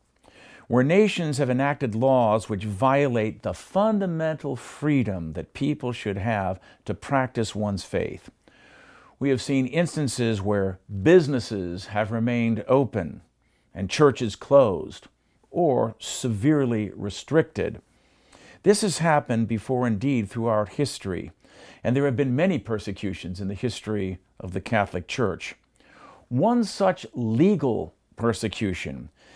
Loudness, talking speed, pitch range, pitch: -24 LUFS, 120 wpm, 105-140 Hz, 115 Hz